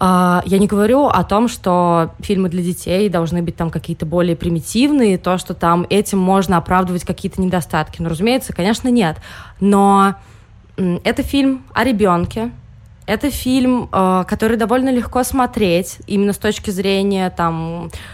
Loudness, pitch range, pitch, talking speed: -16 LUFS, 170-215 Hz, 190 Hz, 140 wpm